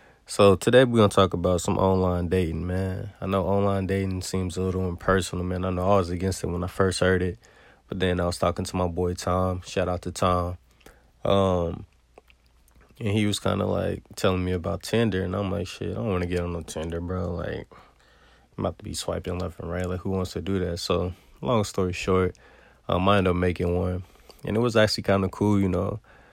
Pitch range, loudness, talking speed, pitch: 90-100 Hz, -25 LUFS, 230 wpm, 95 Hz